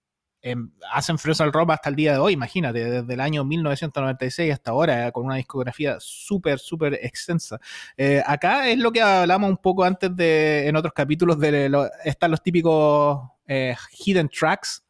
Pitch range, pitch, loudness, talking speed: 135-170 Hz, 150 Hz, -22 LUFS, 180 wpm